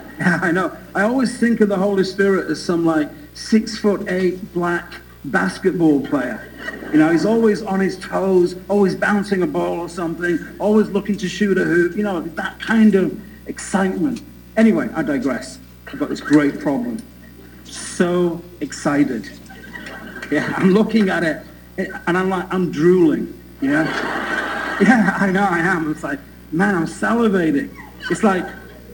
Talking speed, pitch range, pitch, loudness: 160 wpm, 170-210 Hz, 190 Hz, -18 LUFS